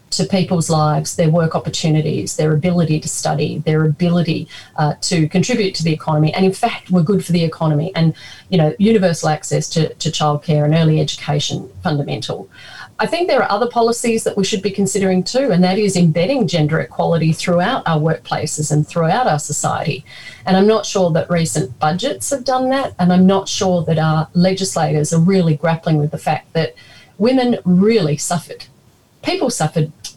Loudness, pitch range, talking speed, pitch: -16 LUFS, 155-190 Hz, 185 wpm, 165 Hz